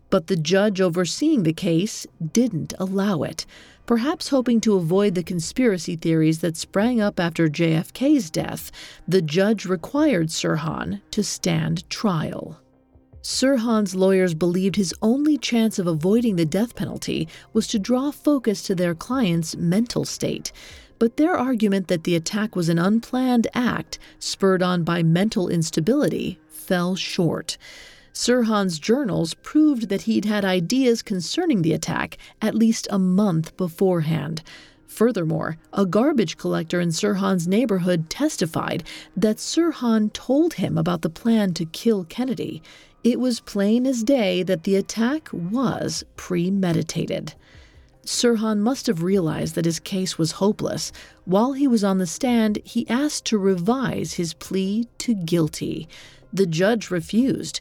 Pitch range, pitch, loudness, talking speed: 175-235 Hz, 195 Hz, -22 LUFS, 140 wpm